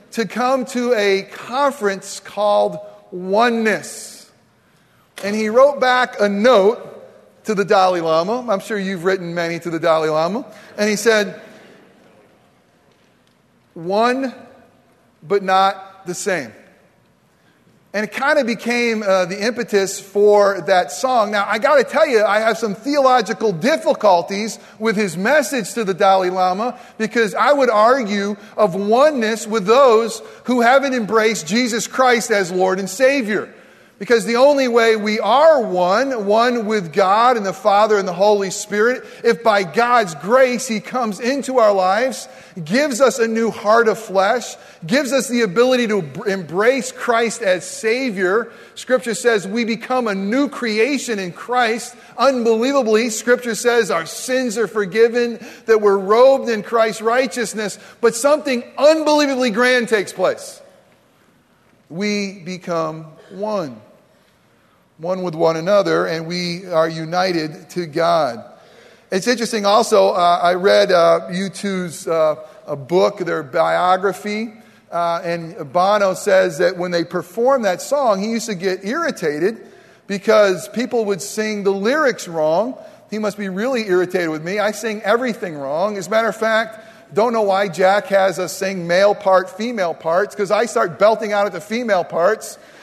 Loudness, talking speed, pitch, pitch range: -17 LUFS, 150 wpm, 215 Hz, 190-240 Hz